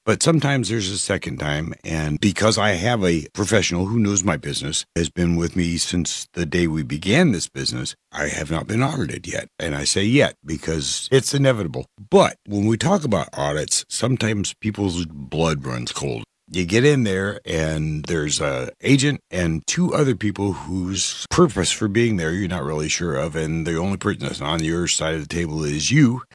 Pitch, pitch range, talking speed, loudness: 90 Hz, 80-110 Hz, 195 wpm, -21 LUFS